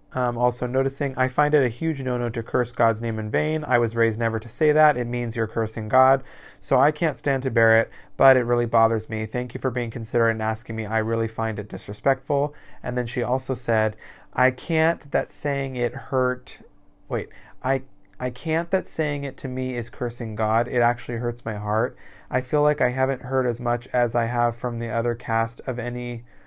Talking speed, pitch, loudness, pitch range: 220 wpm, 125 Hz, -24 LUFS, 115-130 Hz